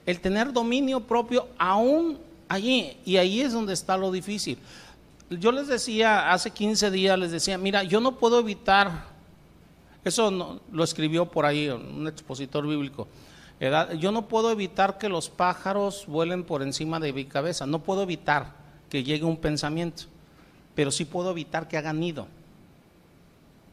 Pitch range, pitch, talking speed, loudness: 155-210 Hz, 180 Hz, 160 wpm, -26 LUFS